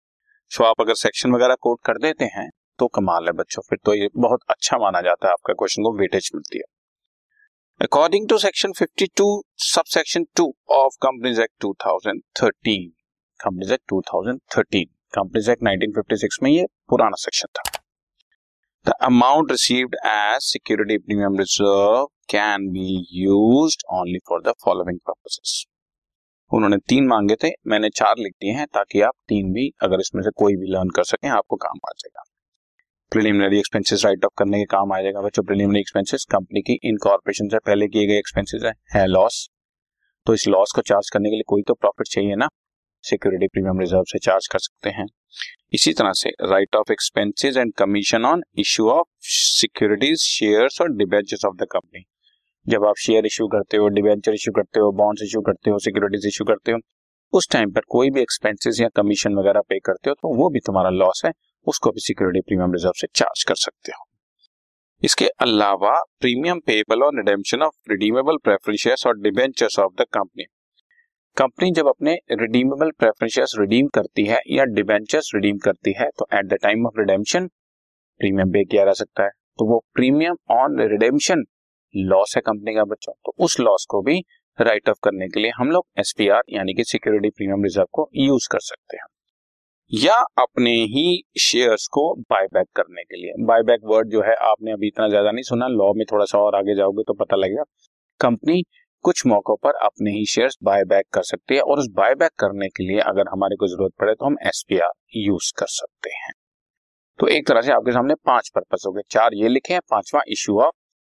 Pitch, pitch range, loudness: 105 Hz, 100-125 Hz, -19 LUFS